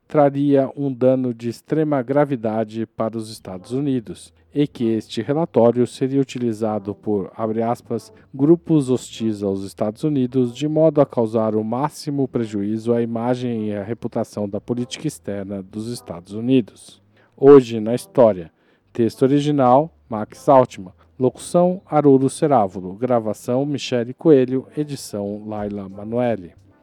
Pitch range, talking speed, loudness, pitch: 105-135 Hz, 130 wpm, -20 LUFS, 120 Hz